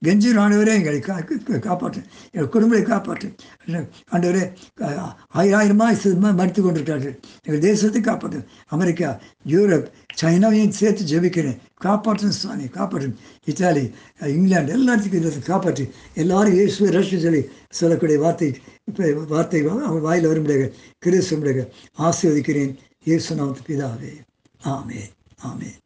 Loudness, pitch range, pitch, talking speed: -20 LUFS, 145-200 Hz, 170 Hz, 100 wpm